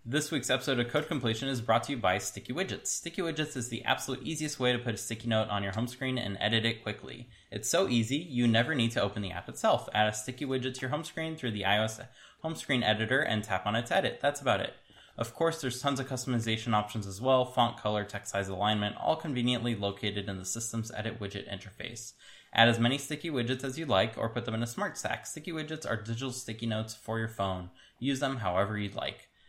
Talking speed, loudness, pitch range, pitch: 240 wpm, -31 LUFS, 105-130 Hz, 115 Hz